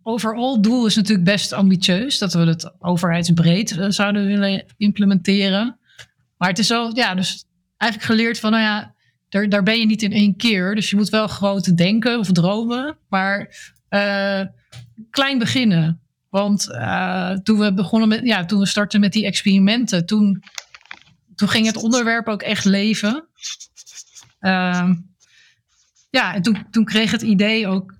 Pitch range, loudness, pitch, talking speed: 190-220 Hz, -18 LUFS, 205 Hz, 160 wpm